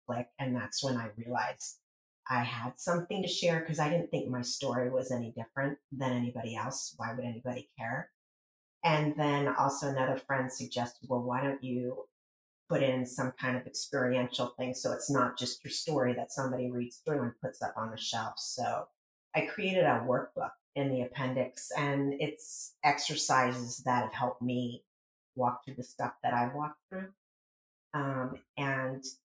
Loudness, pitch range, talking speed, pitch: -34 LUFS, 125-140 Hz, 170 wpm, 130 Hz